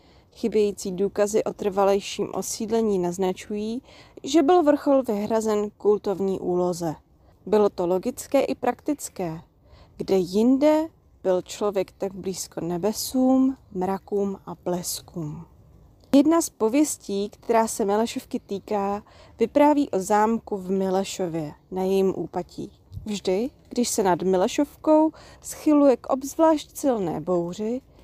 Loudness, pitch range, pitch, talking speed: -24 LUFS, 190-250 Hz, 205 Hz, 110 wpm